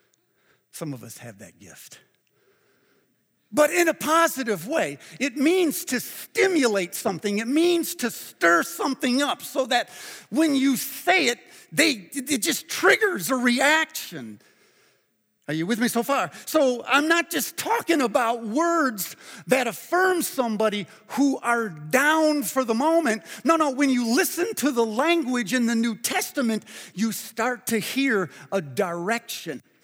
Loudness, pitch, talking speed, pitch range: -23 LUFS, 255 Hz, 150 wpm, 220-305 Hz